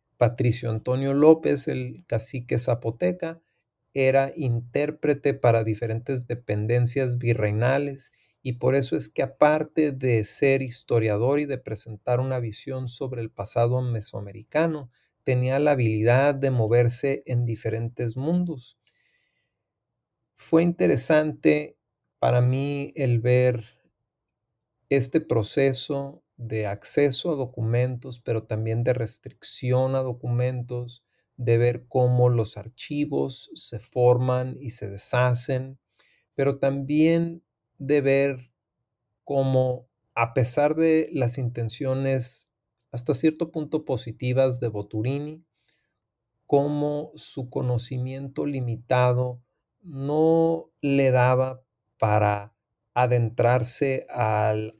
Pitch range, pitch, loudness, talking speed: 115-140 Hz, 125 Hz, -24 LUFS, 100 wpm